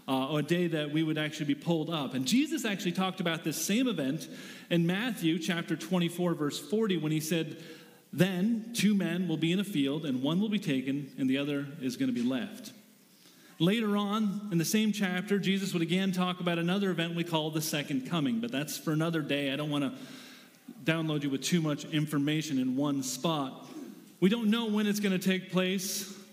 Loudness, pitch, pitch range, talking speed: -31 LUFS, 175 Hz, 155-205 Hz, 215 wpm